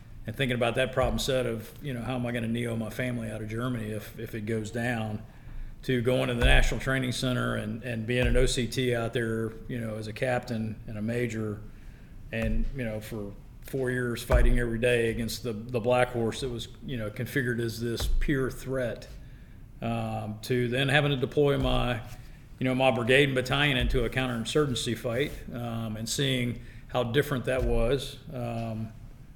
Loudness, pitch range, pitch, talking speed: -29 LUFS, 115-130 Hz, 120 Hz, 195 wpm